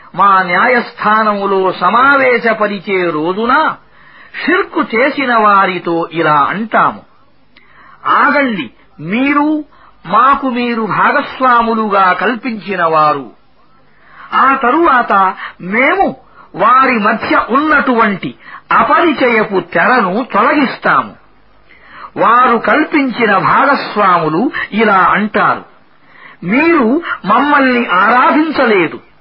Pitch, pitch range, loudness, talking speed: 235 Hz, 195-275 Hz, -11 LUFS, 65 wpm